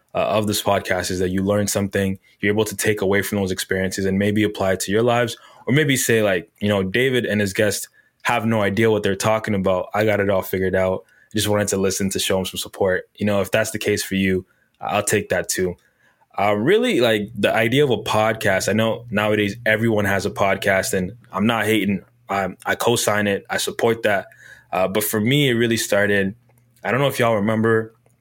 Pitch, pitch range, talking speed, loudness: 105 Hz, 95-110 Hz, 230 wpm, -20 LUFS